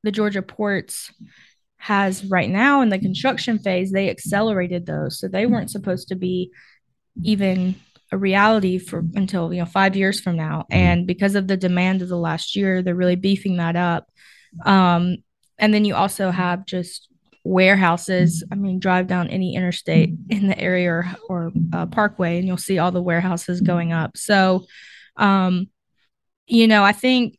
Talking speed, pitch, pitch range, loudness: 175 wpm, 185 Hz, 180-200 Hz, -20 LUFS